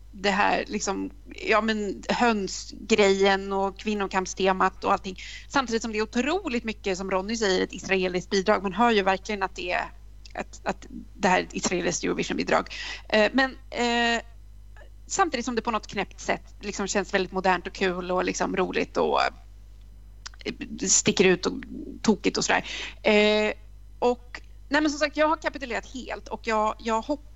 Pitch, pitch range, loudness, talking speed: 215 Hz, 195-240 Hz, -25 LUFS, 170 wpm